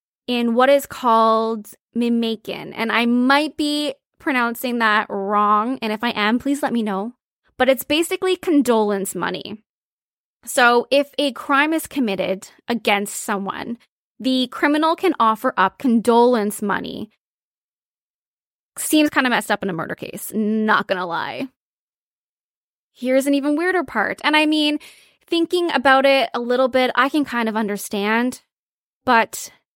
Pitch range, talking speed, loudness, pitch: 220-280 Hz, 145 wpm, -19 LUFS, 245 Hz